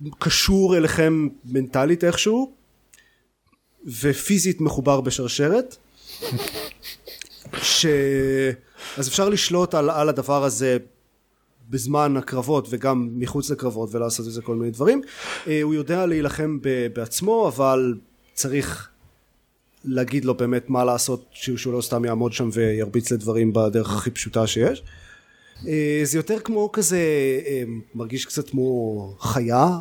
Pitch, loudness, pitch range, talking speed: 135 Hz, -22 LUFS, 120-155 Hz, 115 wpm